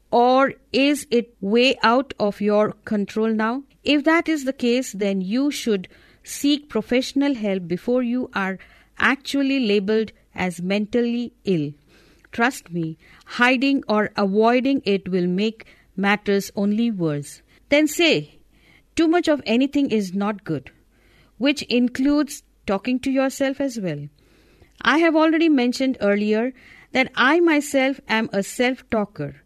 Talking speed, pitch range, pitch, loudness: 135 wpm, 200-270 Hz, 235 Hz, -21 LUFS